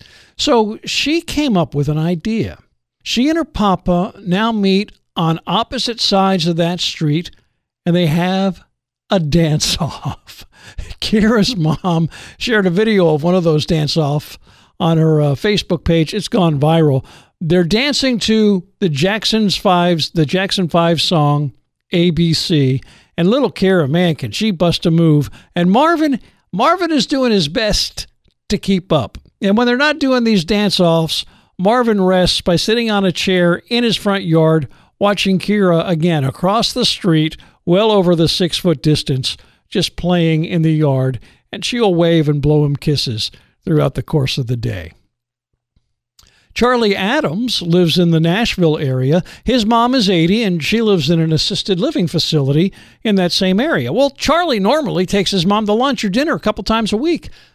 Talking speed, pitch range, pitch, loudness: 170 wpm, 160-210 Hz, 180 Hz, -15 LUFS